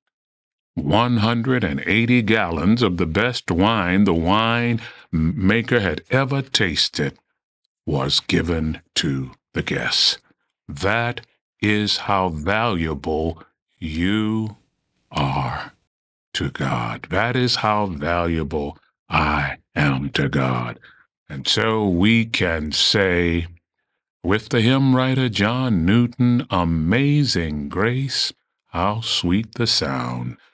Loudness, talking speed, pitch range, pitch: -20 LUFS, 100 wpm, 80-115 Hz, 100 Hz